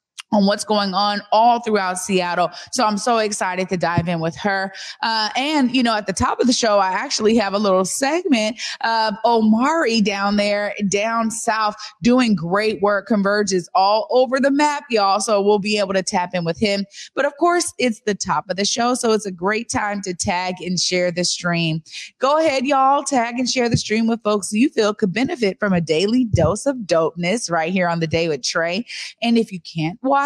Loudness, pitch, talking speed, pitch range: -19 LUFS, 210 Hz, 215 wpm, 185-235 Hz